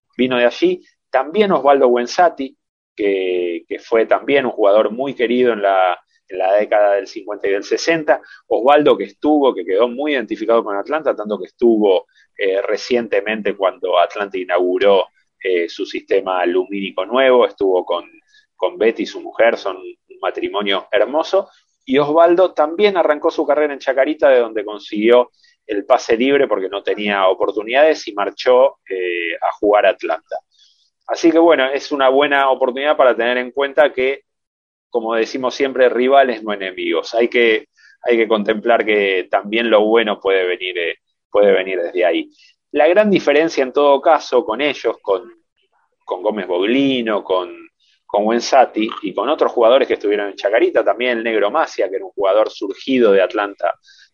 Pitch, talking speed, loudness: 165 Hz, 165 wpm, -16 LUFS